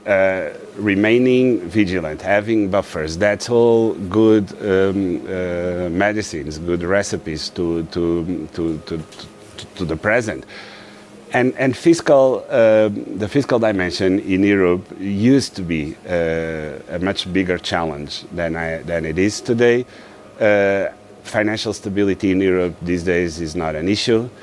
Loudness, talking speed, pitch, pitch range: -18 LUFS, 135 wpm, 95 Hz, 85-105 Hz